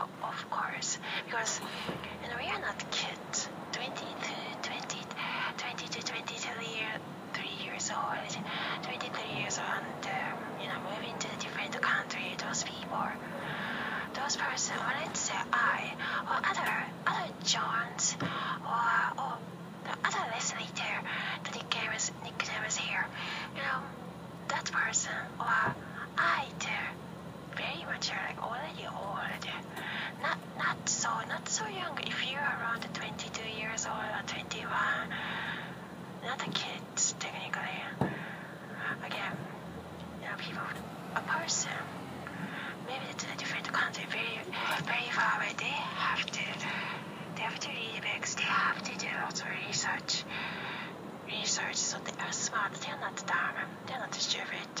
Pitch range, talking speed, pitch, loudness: 175-215 Hz, 140 wpm, 190 Hz, -34 LUFS